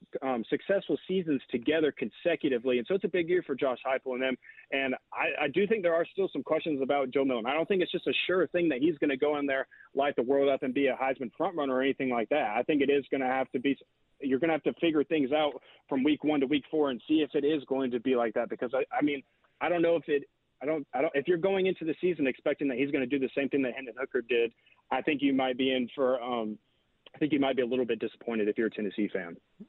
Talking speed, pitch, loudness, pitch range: 295 wpm, 140 Hz, -30 LUFS, 130-160 Hz